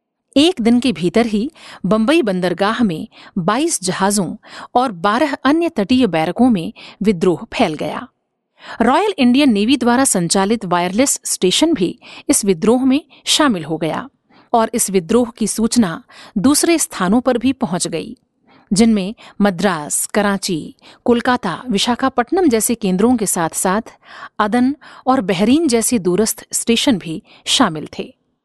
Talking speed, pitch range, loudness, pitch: 135 wpm, 200-260 Hz, -16 LUFS, 230 Hz